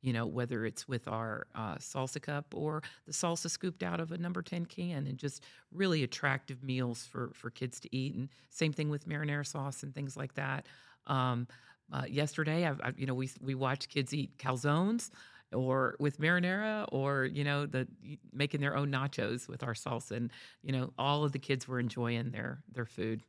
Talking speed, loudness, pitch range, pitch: 200 wpm, -36 LUFS, 125-150 Hz, 135 Hz